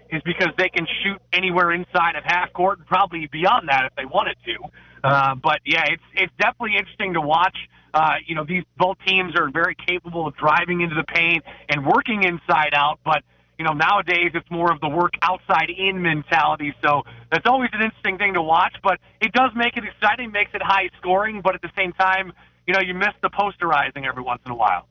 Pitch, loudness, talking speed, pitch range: 175 Hz, -20 LUFS, 215 wpm, 155-195 Hz